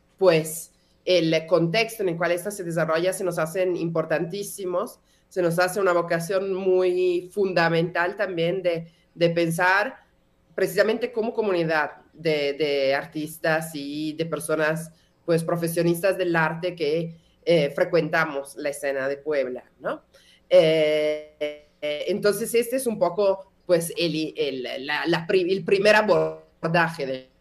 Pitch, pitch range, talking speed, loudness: 170 Hz, 155-185 Hz, 135 wpm, -24 LUFS